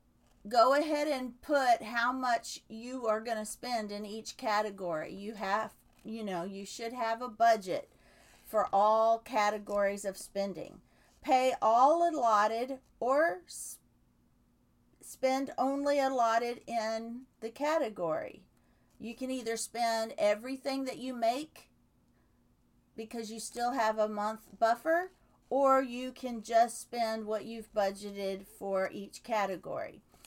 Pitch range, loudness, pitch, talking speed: 215-260 Hz, -32 LUFS, 230 Hz, 125 wpm